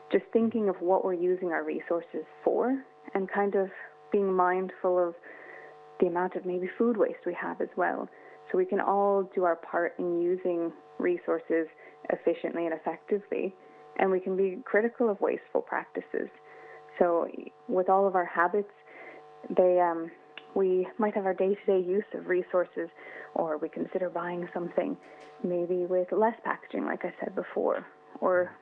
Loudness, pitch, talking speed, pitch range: -29 LUFS, 185 Hz, 160 wpm, 175-195 Hz